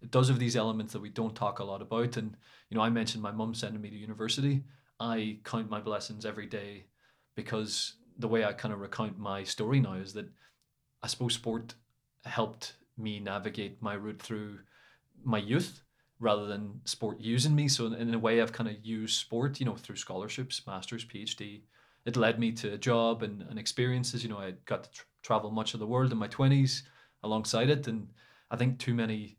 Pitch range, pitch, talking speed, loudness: 105-120 Hz, 115 Hz, 210 wpm, -33 LUFS